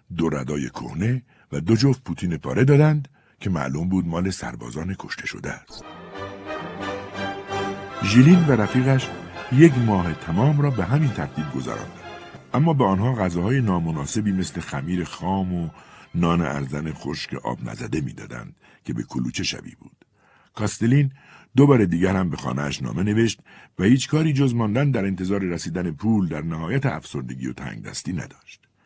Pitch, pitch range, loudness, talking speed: 100 Hz, 85-130 Hz, -22 LUFS, 150 wpm